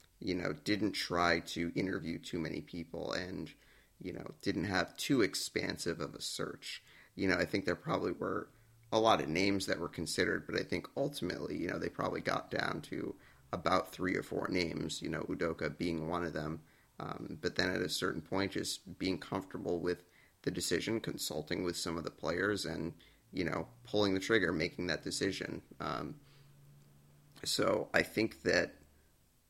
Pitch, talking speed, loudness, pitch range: 85 Hz, 180 wpm, -36 LUFS, 80-105 Hz